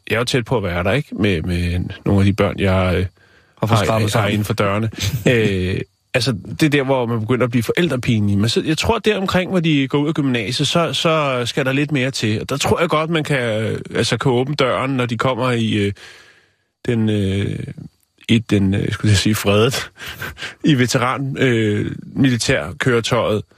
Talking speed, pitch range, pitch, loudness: 205 wpm, 105-135 Hz, 120 Hz, -18 LUFS